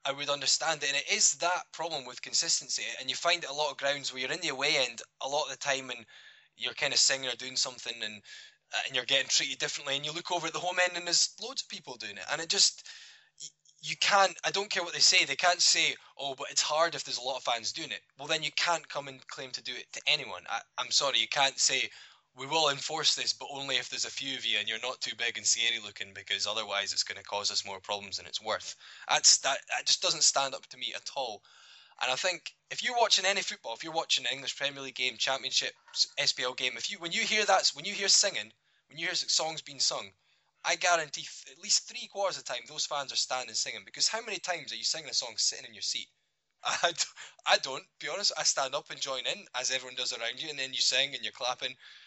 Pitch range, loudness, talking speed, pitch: 130-175 Hz, -29 LUFS, 270 wpm, 145 Hz